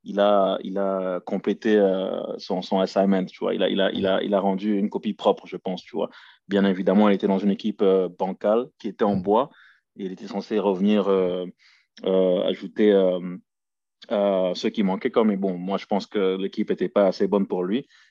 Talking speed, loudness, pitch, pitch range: 220 wpm, -23 LUFS, 95 Hz, 95-100 Hz